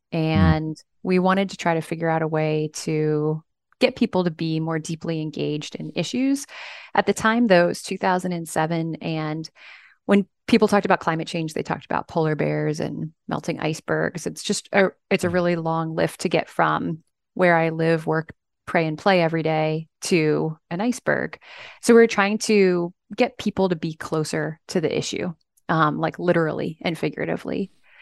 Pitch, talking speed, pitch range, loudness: 165 Hz, 180 wpm, 155-195 Hz, -23 LUFS